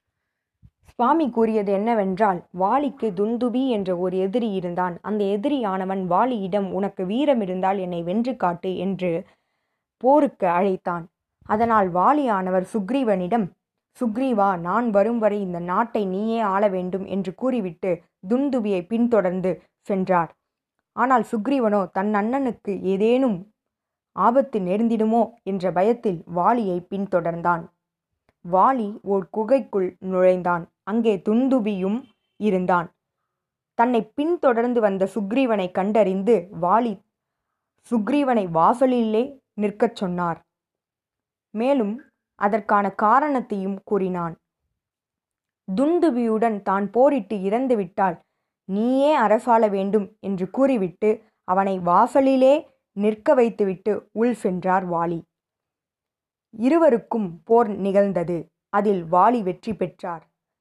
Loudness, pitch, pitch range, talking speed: -22 LUFS, 205 Hz, 185-235 Hz, 90 wpm